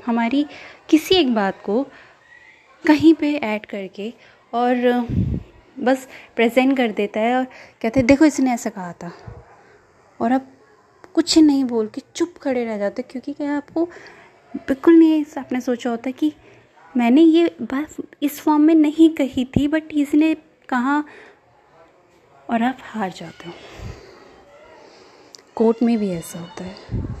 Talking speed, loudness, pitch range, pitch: 145 wpm, -19 LUFS, 230-315 Hz, 265 Hz